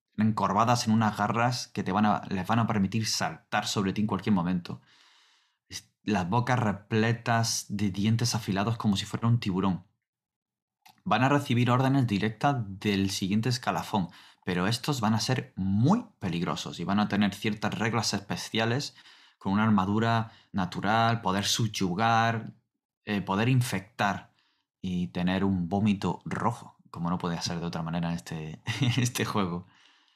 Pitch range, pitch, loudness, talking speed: 95-115 Hz, 105 Hz, -28 LUFS, 150 wpm